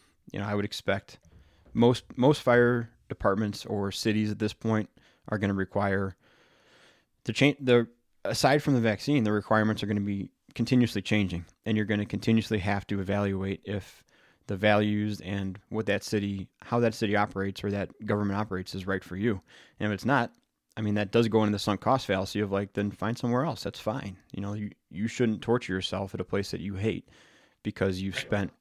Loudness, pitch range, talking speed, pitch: -29 LUFS, 100-110 Hz, 200 wpm, 105 Hz